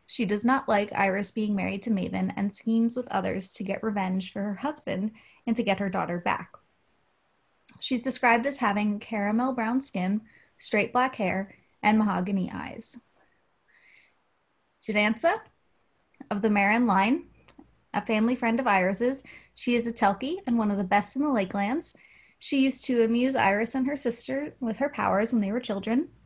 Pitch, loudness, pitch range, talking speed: 225 Hz, -27 LUFS, 200-255 Hz, 170 wpm